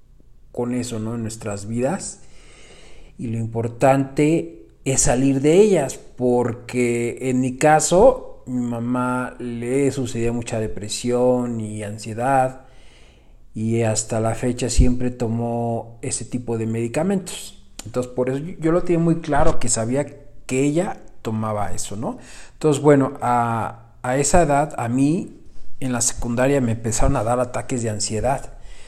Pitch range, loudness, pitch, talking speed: 115-135 Hz, -21 LUFS, 125 Hz, 140 wpm